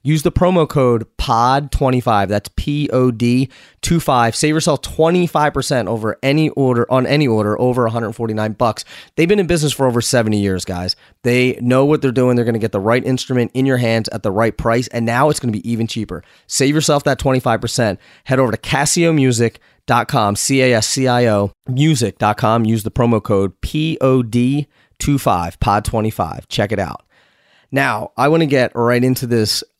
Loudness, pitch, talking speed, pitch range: -16 LUFS, 125 Hz, 175 wpm, 110-140 Hz